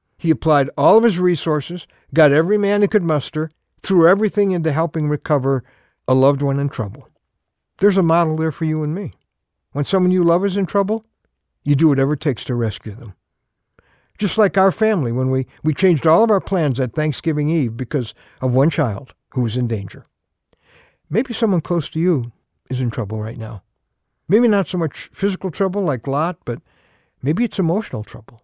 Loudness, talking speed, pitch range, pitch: -18 LUFS, 190 wpm, 130-185 Hz, 155 Hz